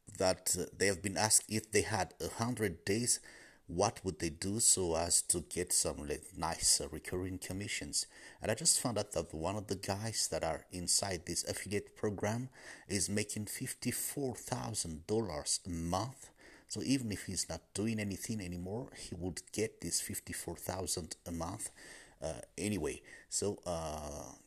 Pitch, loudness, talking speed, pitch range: 95 Hz, -36 LUFS, 160 wpm, 90-110 Hz